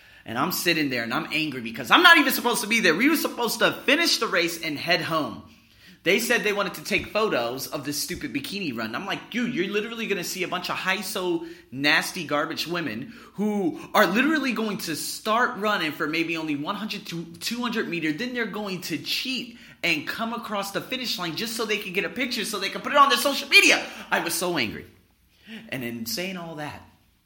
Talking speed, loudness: 230 wpm, -24 LUFS